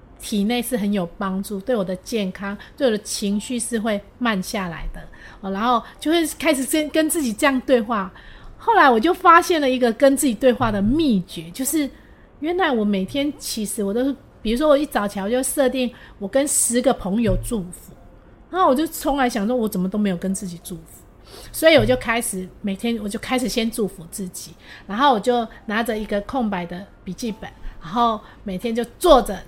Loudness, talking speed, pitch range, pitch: -20 LUFS, 295 characters per minute, 200-265 Hz, 235 Hz